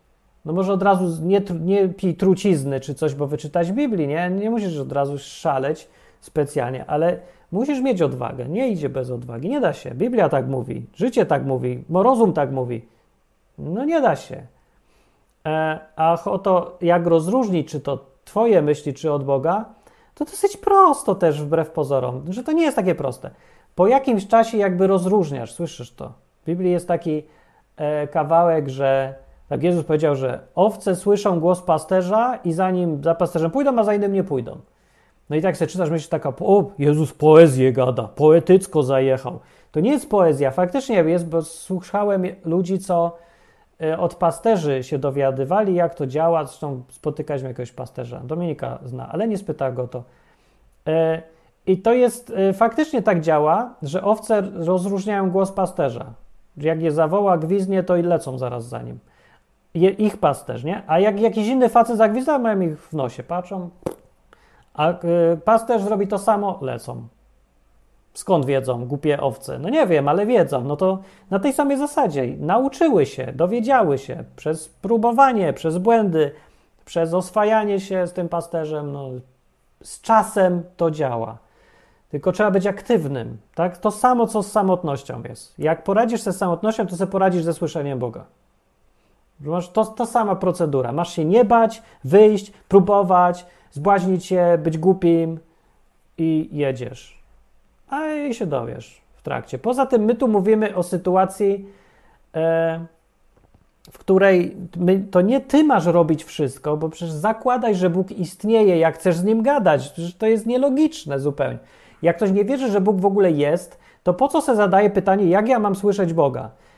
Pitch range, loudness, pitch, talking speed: 150-205 Hz, -20 LUFS, 175 Hz, 160 wpm